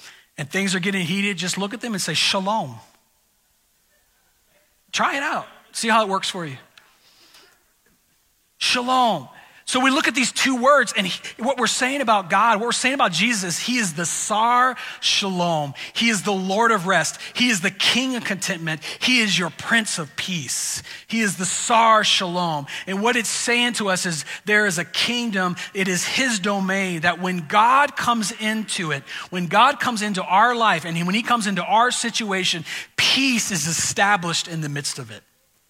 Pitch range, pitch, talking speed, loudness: 180-235 Hz, 200 Hz, 185 wpm, -20 LUFS